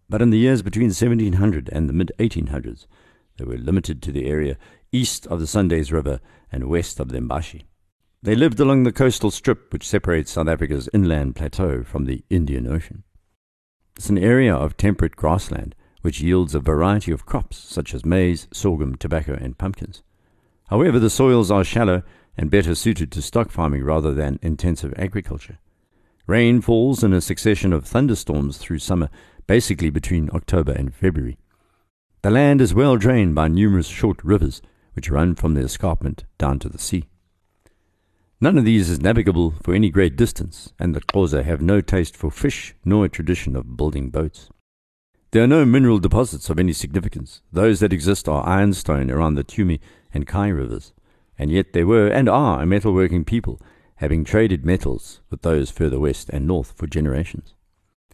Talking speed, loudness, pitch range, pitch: 175 wpm, -20 LUFS, 80-105 Hz, 90 Hz